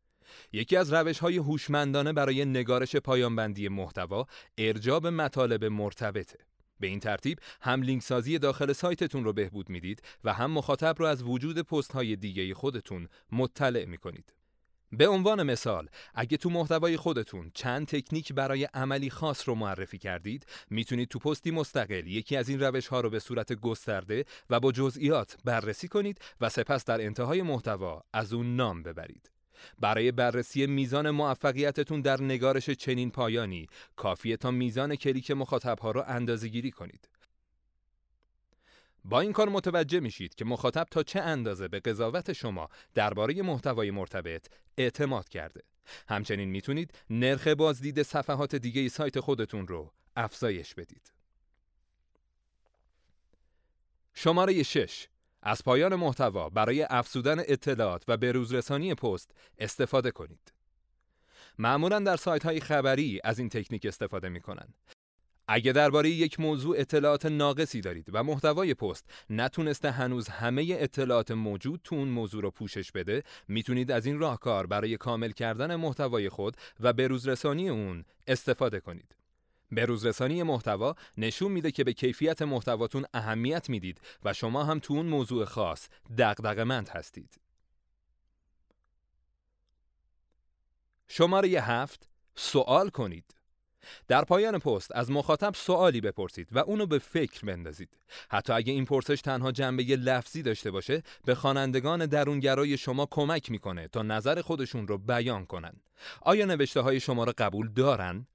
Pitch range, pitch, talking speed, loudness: 110-145 Hz, 125 Hz, 140 wpm, -30 LUFS